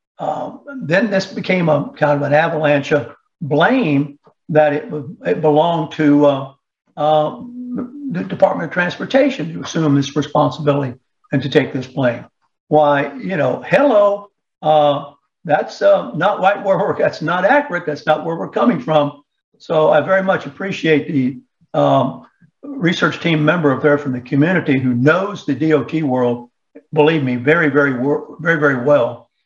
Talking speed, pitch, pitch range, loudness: 155 wpm, 150 Hz, 145-175 Hz, -16 LUFS